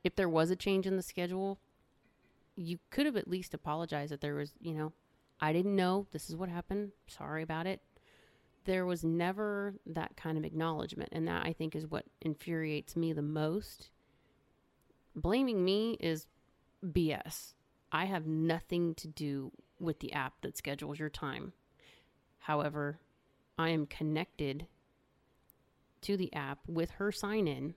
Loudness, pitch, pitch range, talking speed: -37 LUFS, 165 Hz, 155-185 Hz, 160 wpm